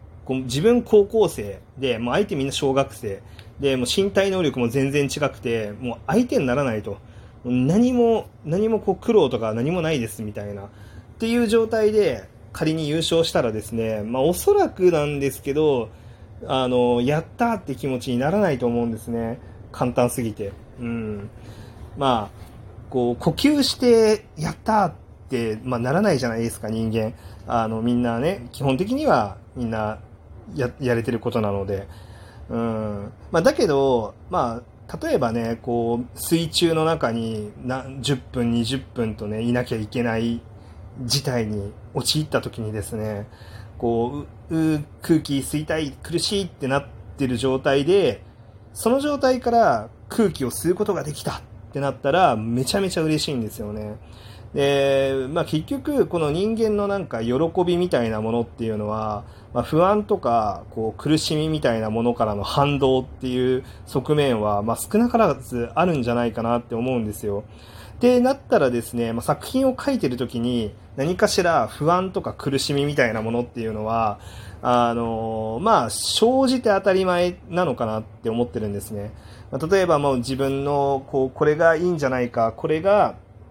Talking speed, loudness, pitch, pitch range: 325 characters per minute, -22 LUFS, 125 Hz, 110-155 Hz